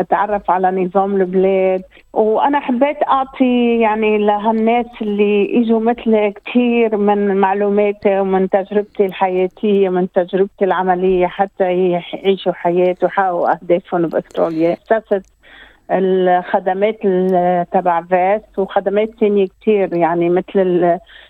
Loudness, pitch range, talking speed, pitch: -15 LUFS, 185-210 Hz, 100 wpm, 195 Hz